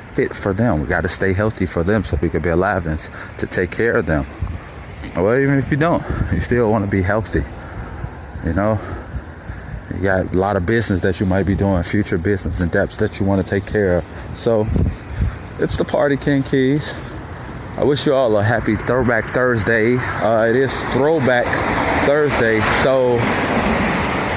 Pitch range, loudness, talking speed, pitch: 90-115 Hz, -18 LUFS, 185 wpm, 100 Hz